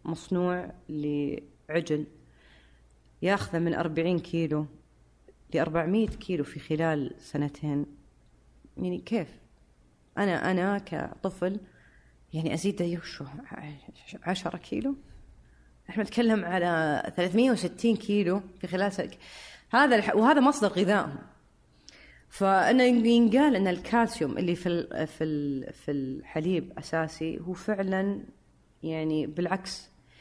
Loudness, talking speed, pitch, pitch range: -28 LUFS, 95 wpm, 170 Hz, 145-195 Hz